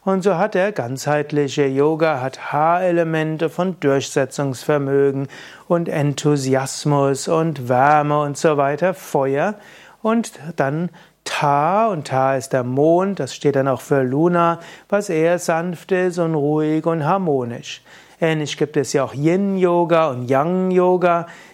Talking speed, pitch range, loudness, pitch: 135 wpm, 140-175 Hz, -19 LUFS, 155 Hz